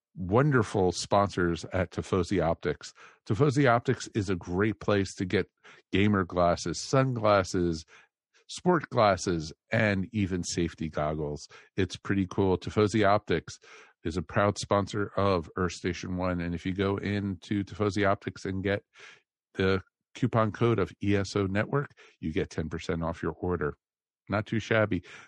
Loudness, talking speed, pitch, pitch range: -29 LUFS, 140 wpm, 100 Hz, 90-105 Hz